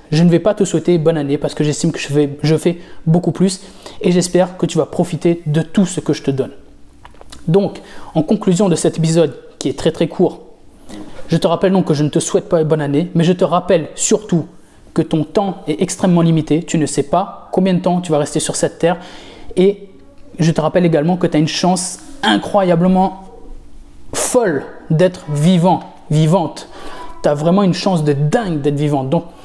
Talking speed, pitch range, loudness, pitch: 210 wpm, 155-185 Hz, -15 LUFS, 165 Hz